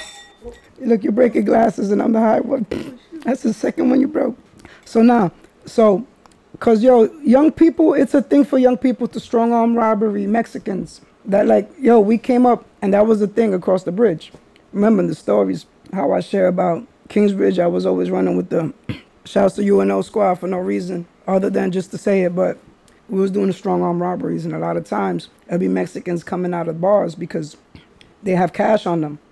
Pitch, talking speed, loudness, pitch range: 205 Hz, 205 wpm, -17 LUFS, 180-235 Hz